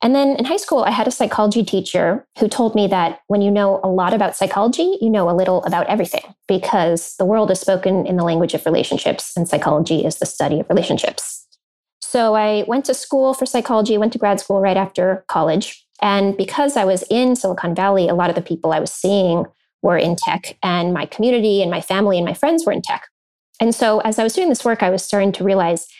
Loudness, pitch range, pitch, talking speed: -17 LUFS, 180-225 Hz, 195 Hz, 235 wpm